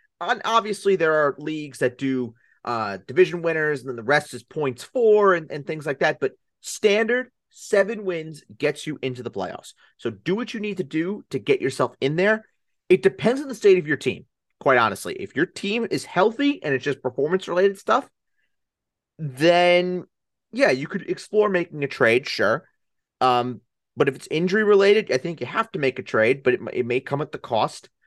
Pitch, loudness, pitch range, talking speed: 170 Hz, -22 LUFS, 135-205 Hz, 200 wpm